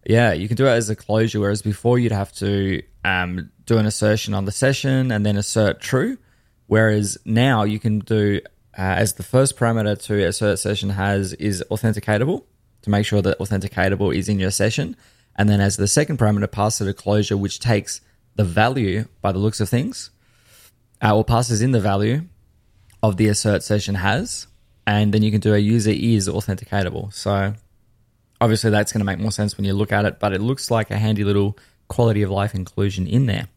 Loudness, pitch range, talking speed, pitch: -20 LUFS, 100-110 Hz, 205 wpm, 105 Hz